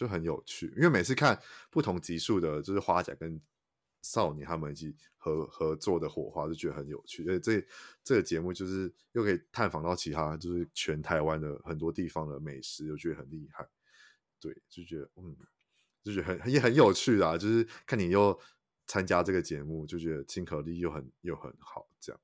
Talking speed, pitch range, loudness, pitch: 300 characters per minute, 75-90 Hz, -32 LUFS, 80 Hz